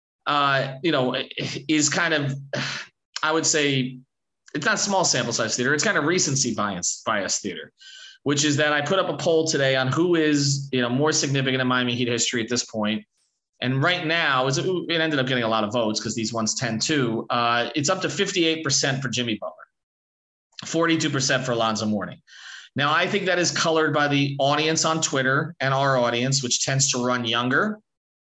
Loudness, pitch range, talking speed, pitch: -22 LUFS, 125-160 Hz, 205 wpm, 140 Hz